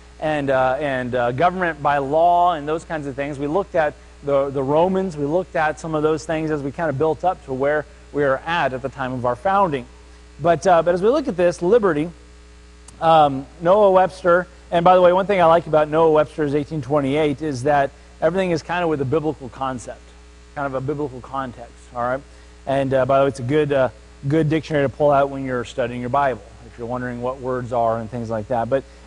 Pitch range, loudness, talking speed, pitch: 130-160 Hz, -20 LUFS, 235 wpm, 145 Hz